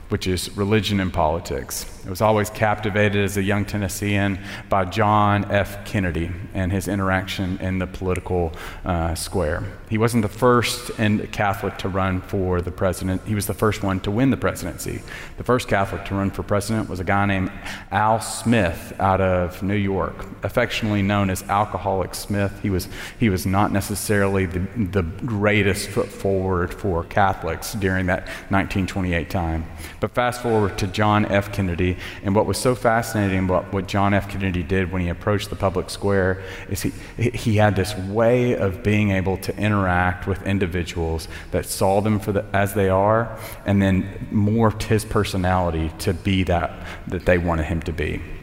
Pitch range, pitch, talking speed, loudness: 95-105 Hz, 100 Hz, 175 wpm, -22 LUFS